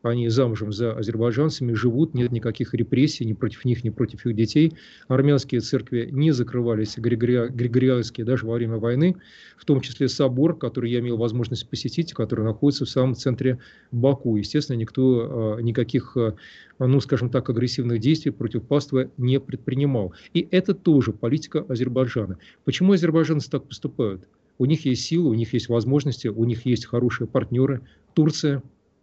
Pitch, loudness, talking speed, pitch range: 125 Hz, -23 LUFS, 155 wpm, 115-140 Hz